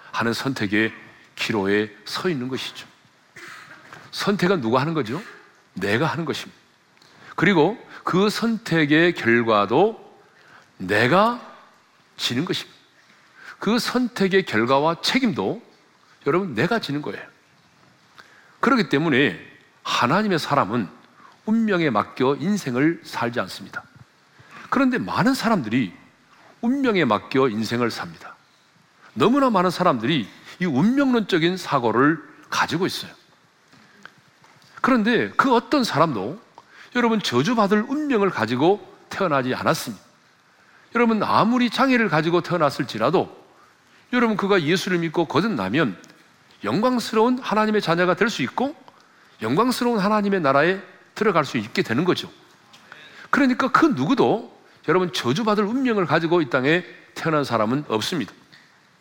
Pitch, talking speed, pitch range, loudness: 195 Hz, 280 characters per minute, 145-230 Hz, -21 LUFS